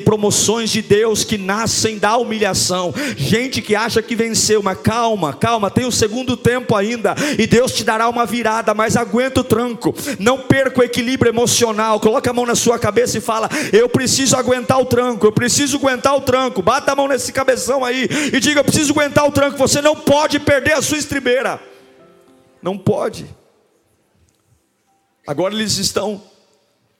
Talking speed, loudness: 175 wpm, -15 LUFS